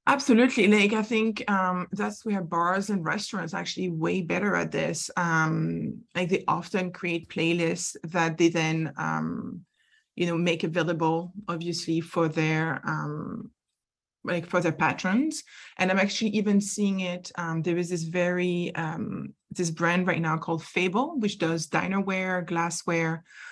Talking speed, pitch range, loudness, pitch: 155 wpm, 165-200 Hz, -27 LUFS, 175 Hz